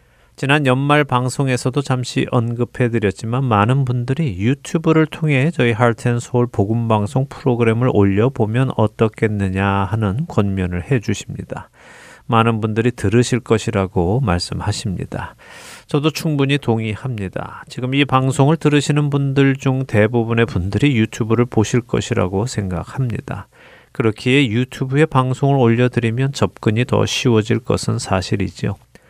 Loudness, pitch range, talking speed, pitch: -17 LUFS, 110-135 Hz, 320 characters per minute, 120 Hz